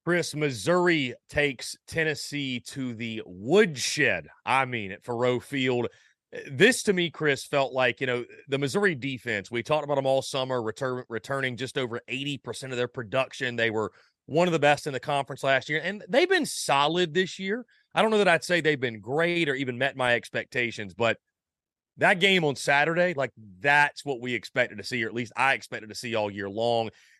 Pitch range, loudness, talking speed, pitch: 120-155 Hz, -26 LUFS, 200 wpm, 135 Hz